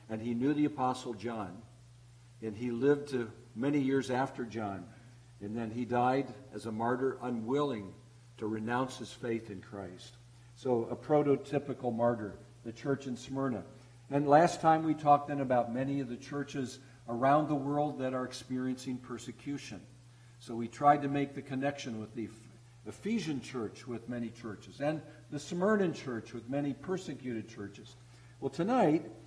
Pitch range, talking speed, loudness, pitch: 120-140 Hz, 160 wpm, -34 LUFS, 125 Hz